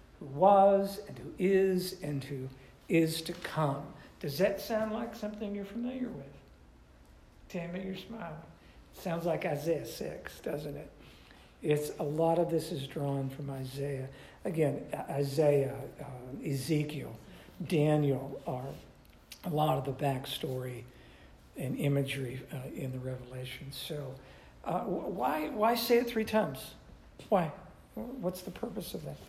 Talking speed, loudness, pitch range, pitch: 140 wpm, -33 LUFS, 135-185 Hz, 150 Hz